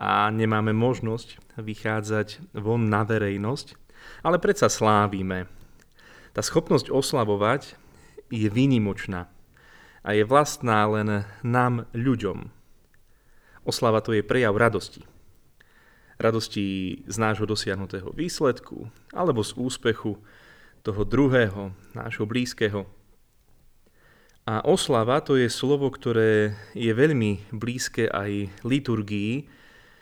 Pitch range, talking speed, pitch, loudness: 105-120 Hz, 100 wpm, 110 Hz, -25 LUFS